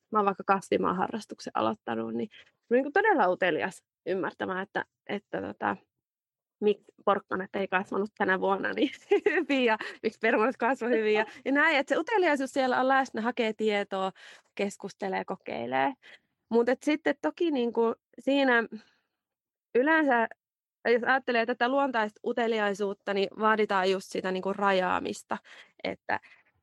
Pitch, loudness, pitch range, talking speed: 225 Hz, -28 LUFS, 200-260 Hz, 135 wpm